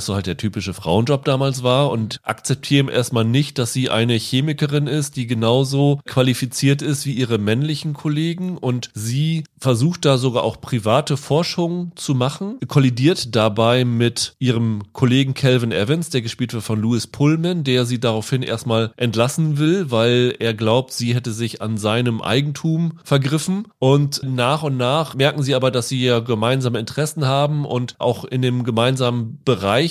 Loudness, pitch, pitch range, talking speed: -19 LUFS, 130 Hz, 120-145 Hz, 165 wpm